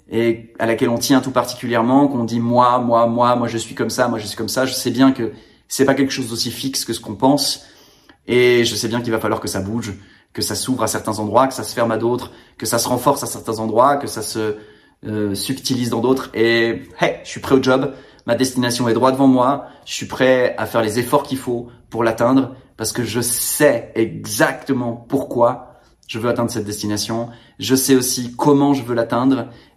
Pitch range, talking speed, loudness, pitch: 115-130 Hz, 230 wpm, -18 LUFS, 120 Hz